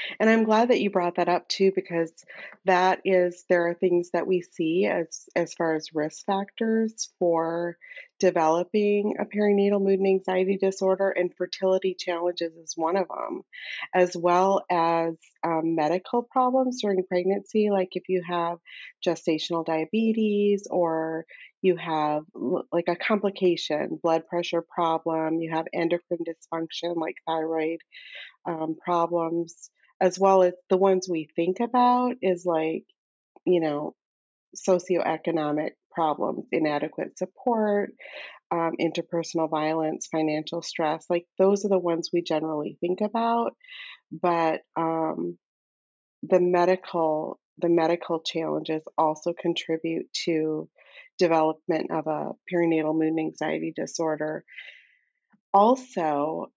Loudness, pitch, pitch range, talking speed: -26 LUFS, 175 Hz, 160-190 Hz, 125 wpm